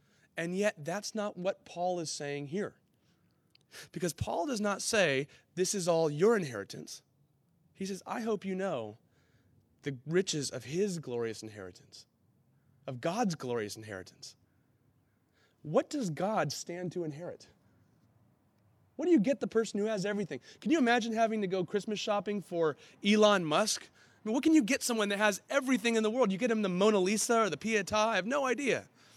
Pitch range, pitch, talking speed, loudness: 145-215 Hz, 190 Hz, 180 wpm, -32 LUFS